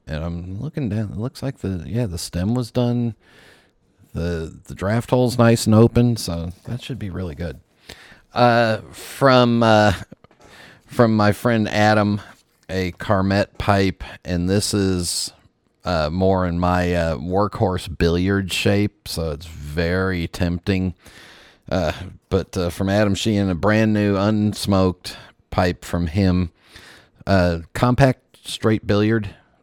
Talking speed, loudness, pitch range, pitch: 140 wpm, -20 LUFS, 90-110 Hz, 100 Hz